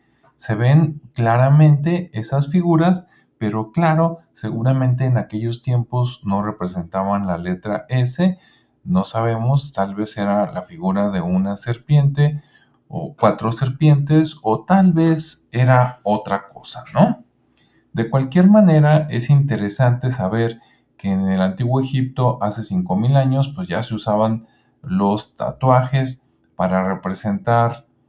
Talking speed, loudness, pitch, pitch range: 125 wpm, -18 LUFS, 125 Hz, 110-150 Hz